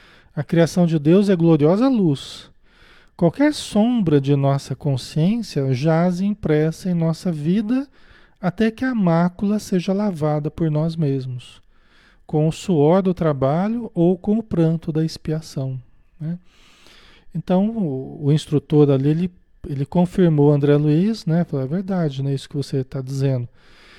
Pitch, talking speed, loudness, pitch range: 165 Hz, 145 wpm, -20 LUFS, 145-185 Hz